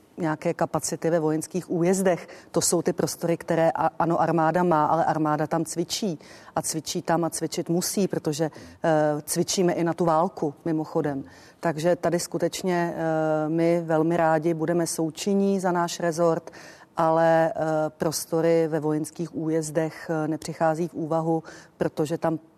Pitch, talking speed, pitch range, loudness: 165 Hz, 145 wpm, 160-170 Hz, -25 LUFS